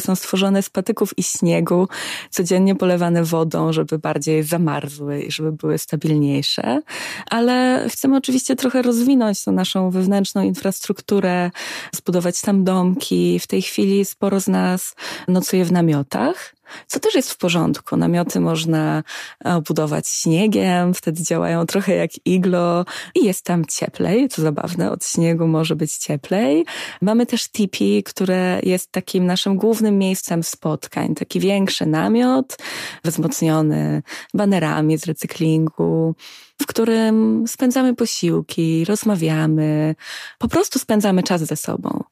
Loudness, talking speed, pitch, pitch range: -19 LUFS, 130 wpm, 180 Hz, 160-210 Hz